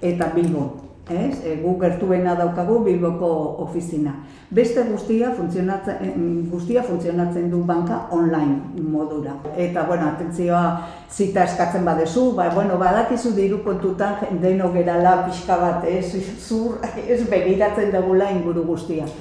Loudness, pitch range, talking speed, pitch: -21 LUFS, 170-195 Hz, 120 wpm, 175 Hz